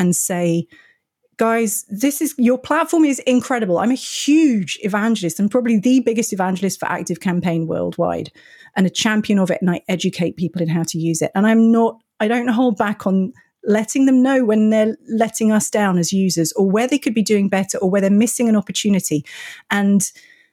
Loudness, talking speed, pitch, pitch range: -18 LUFS, 200 wpm, 215 Hz, 185-245 Hz